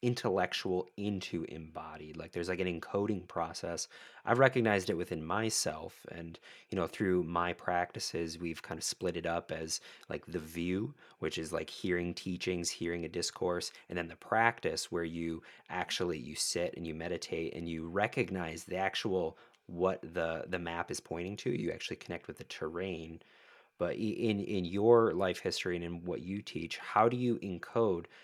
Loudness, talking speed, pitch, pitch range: -35 LUFS, 175 wpm, 90 Hz, 85-100 Hz